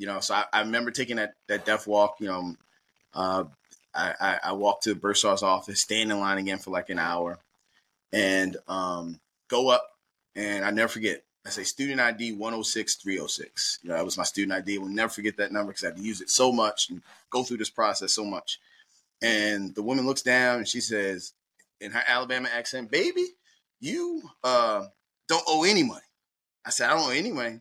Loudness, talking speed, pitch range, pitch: -27 LUFS, 215 wpm, 95-125 Hz, 105 Hz